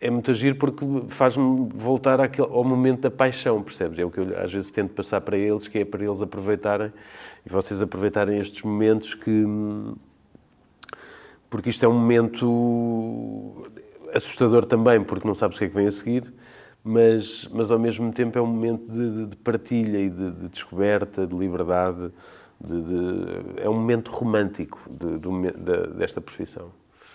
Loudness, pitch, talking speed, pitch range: -24 LUFS, 115 Hz, 175 wpm, 100-120 Hz